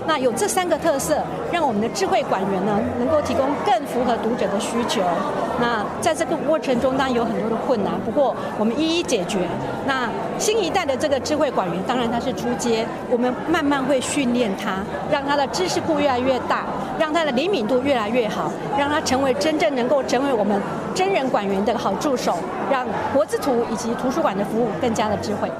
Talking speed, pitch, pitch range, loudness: 310 characters per minute, 265 Hz, 235-305 Hz, -21 LUFS